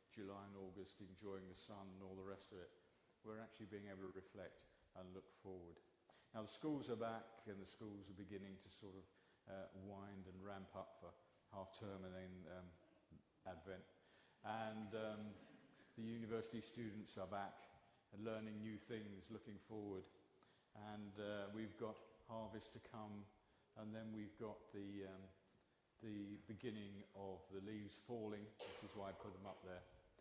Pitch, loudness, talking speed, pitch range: 100 Hz, -55 LUFS, 170 wpm, 95-110 Hz